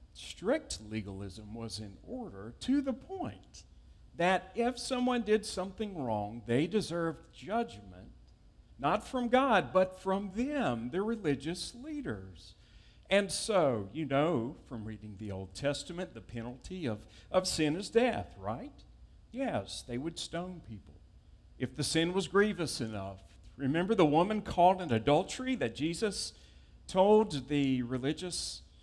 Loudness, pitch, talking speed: -33 LUFS, 150 Hz, 135 wpm